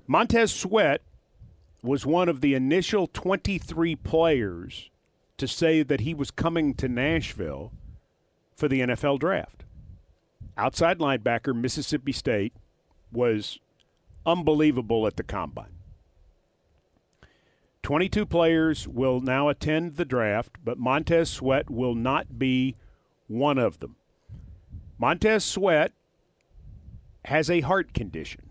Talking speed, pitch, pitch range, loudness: 110 wpm, 135 Hz, 110-160 Hz, -25 LUFS